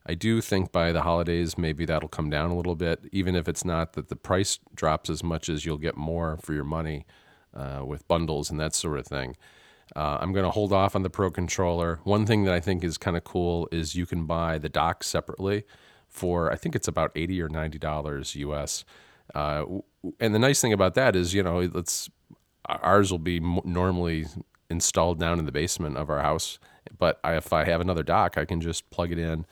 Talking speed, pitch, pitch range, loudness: 220 wpm, 85 Hz, 80-90 Hz, -27 LUFS